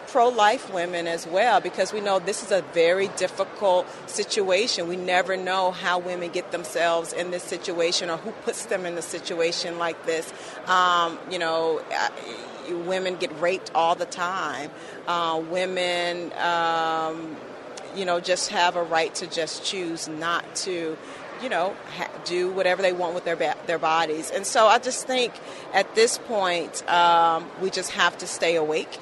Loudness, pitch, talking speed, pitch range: -24 LUFS, 175 Hz, 175 wpm, 170-190 Hz